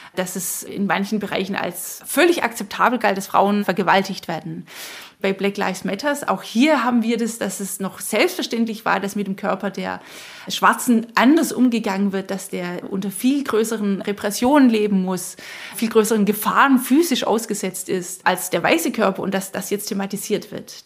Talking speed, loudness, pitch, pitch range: 175 wpm, -20 LUFS, 205 Hz, 195-230 Hz